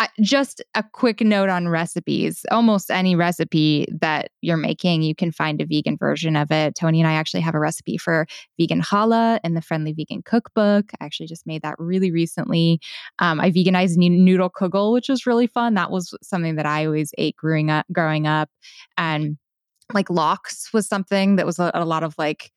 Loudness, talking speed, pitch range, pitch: -20 LUFS, 200 wpm, 160-200 Hz, 175 Hz